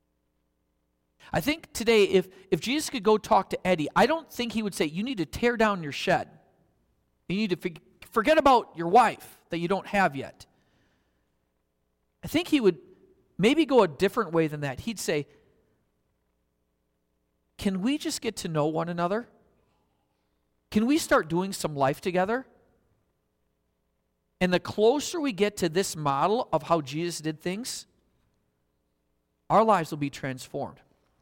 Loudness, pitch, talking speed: -26 LUFS, 175 Hz, 160 wpm